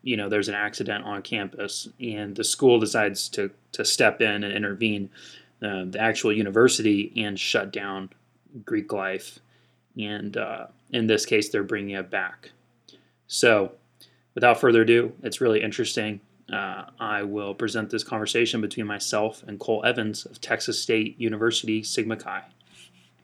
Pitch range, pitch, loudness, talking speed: 100-110 Hz, 105 Hz, -25 LUFS, 150 wpm